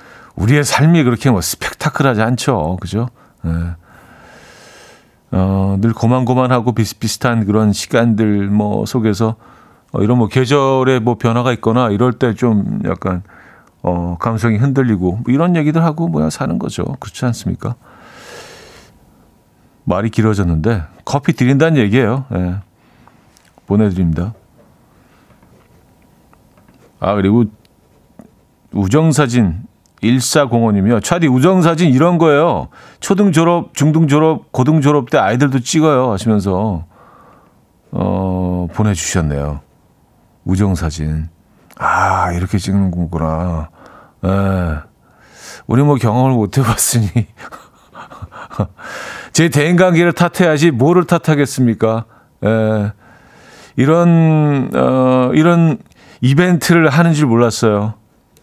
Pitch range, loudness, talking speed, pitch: 100-145 Hz, -14 LUFS, 235 characters per minute, 115 Hz